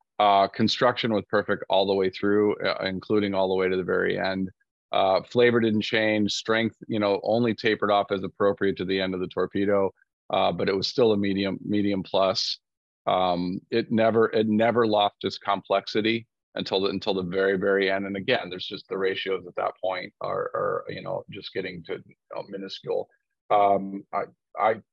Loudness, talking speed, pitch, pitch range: -25 LUFS, 195 wpm, 100 Hz, 95-110 Hz